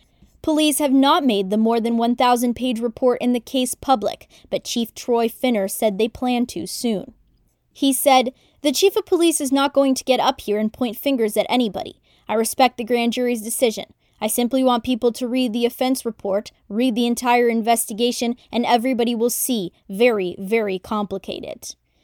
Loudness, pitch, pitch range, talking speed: -20 LUFS, 240 Hz, 225-255 Hz, 180 wpm